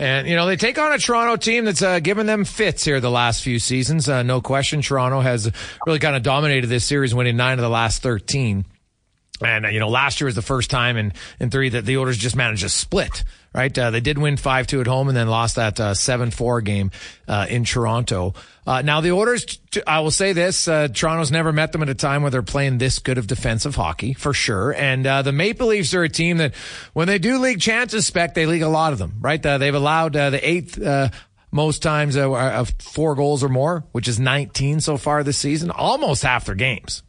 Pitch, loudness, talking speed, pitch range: 135 Hz, -19 LUFS, 240 wpm, 120-155 Hz